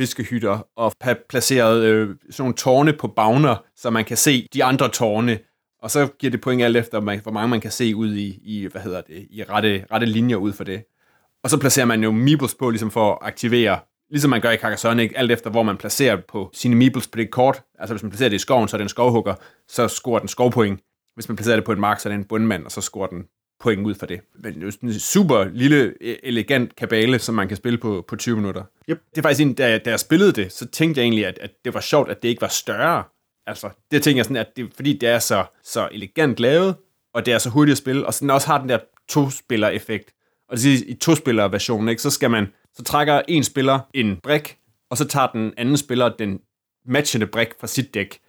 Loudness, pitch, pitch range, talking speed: -20 LUFS, 115 Hz, 110-130 Hz, 245 wpm